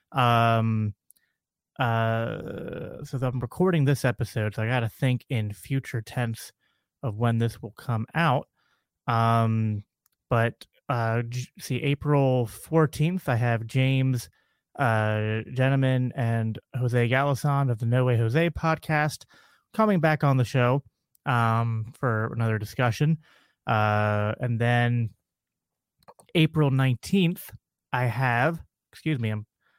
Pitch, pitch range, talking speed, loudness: 125 Hz, 115-140 Hz, 125 wpm, -26 LUFS